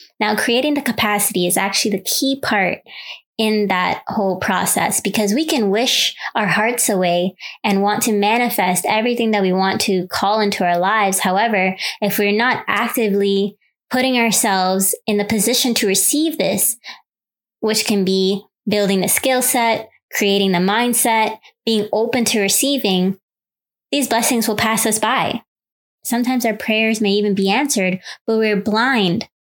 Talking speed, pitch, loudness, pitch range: 155 wpm, 215 Hz, -17 LUFS, 195-230 Hz